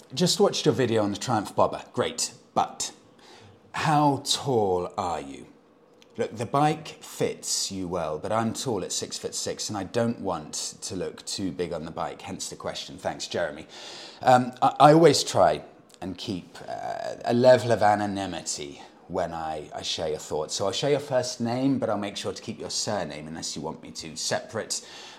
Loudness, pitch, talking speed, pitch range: -26 LUFS, 120 Hz, 195 wpm, 100-140 Hz